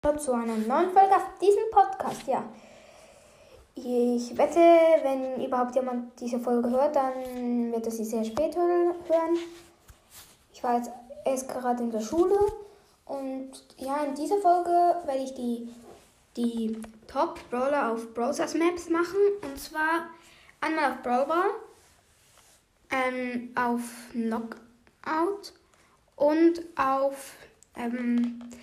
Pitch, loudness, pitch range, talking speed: 275 Hz, -27 LUFS, 245-335 Hz, 120 wpm